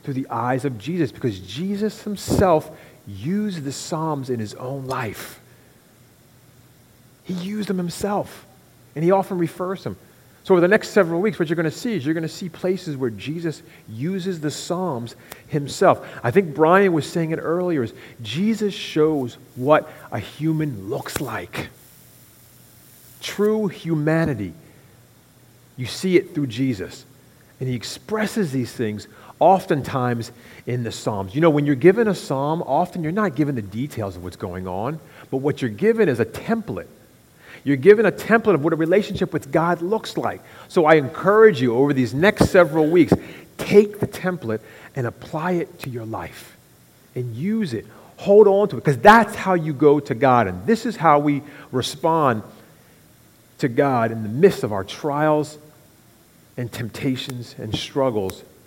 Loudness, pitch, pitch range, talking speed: -21 LUFS, 150 Hz, 125-185 Hz, 170 wpm